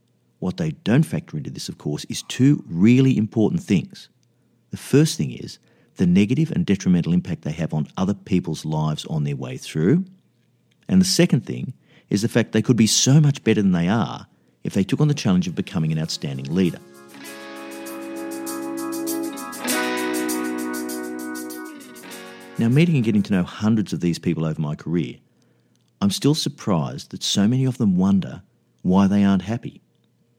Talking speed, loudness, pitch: 170 wpm, -21 LUFS, 110 Hz